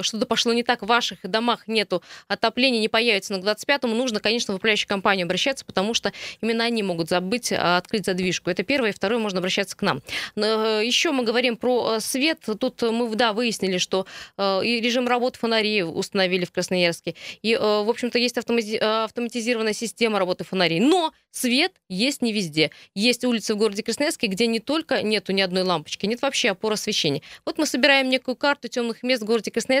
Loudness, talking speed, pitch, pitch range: -22 LUFS, 185 wpm, 225 Hz, 195-245 Hz